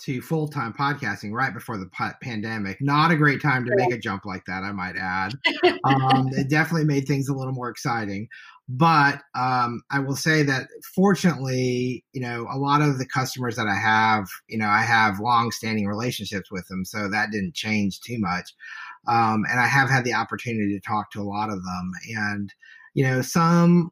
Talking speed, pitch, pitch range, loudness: 200 wpm, 125 Hz, 105-140 Hz, -23 LUFS